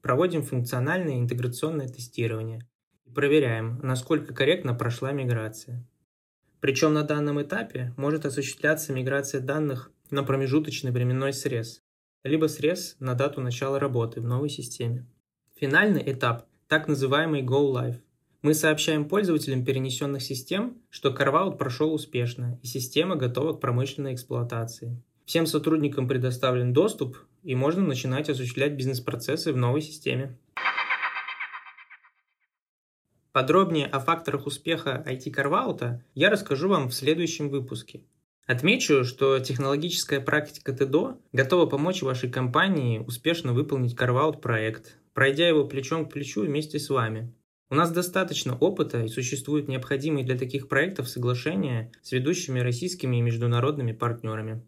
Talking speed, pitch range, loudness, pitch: 125 wpm, 125-150 Hz, -26 LUFS, 135 Hz